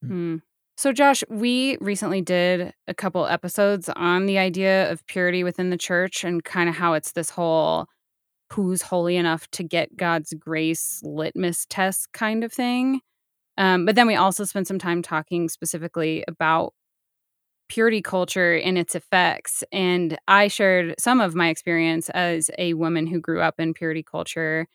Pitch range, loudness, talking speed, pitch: 165-190 Hz, -22 LUFS, 165 wpm, 180 Hz